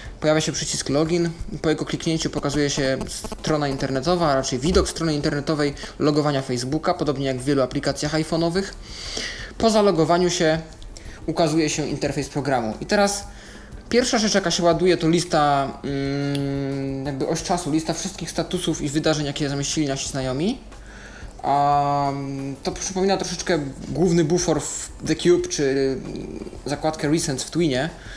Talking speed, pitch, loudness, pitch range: 140 wpm, 155 Hz, -22 LUFS, 140-170 Hz